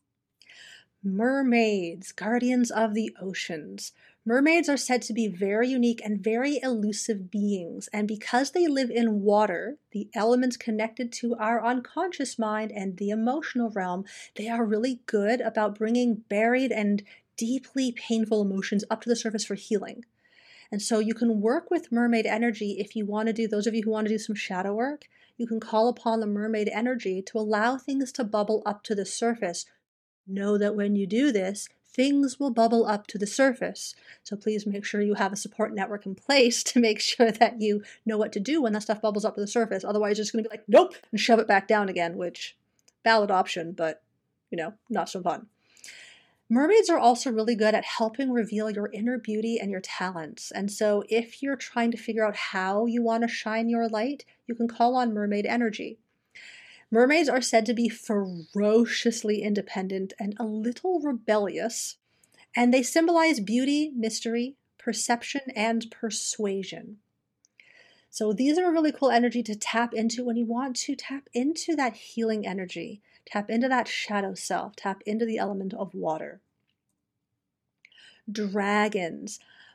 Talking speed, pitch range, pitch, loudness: 180 wpm, 210-240 Hz, 225 Hz, -26 LUFS